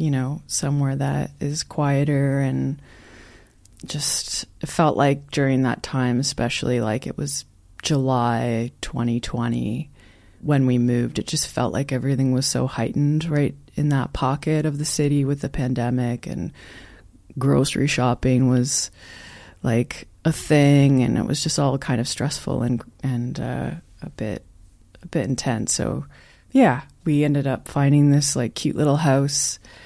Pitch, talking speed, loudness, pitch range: 135 Hz, 150 wpm, -22 LUFS, 120-145 Hz